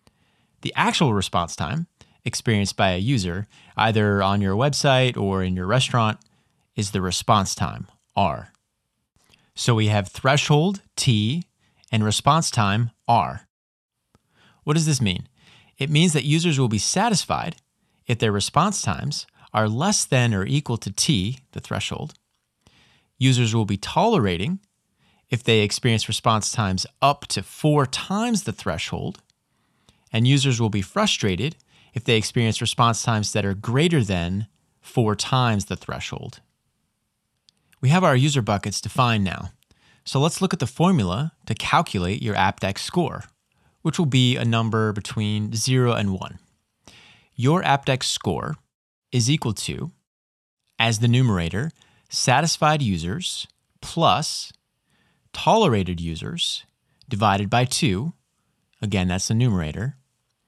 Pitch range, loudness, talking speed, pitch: 105-140 Hz, -22 LUFS, 135 wpm, 115 Hz